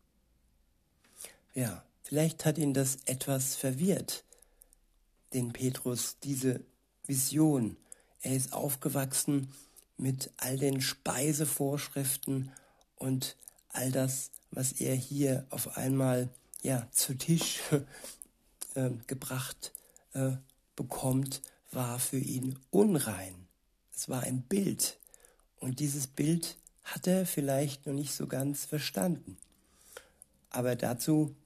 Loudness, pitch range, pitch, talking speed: -33 LUFS, 130-145 Hz, 135 Hz, 105 wpm